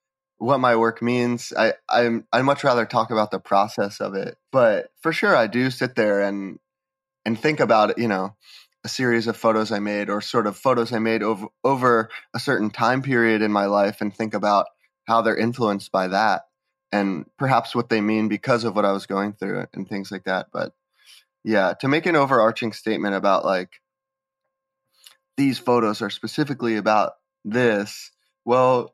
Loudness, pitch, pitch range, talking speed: -22 LUFS, 115 Hz, 105-125 Hz, 185 wpm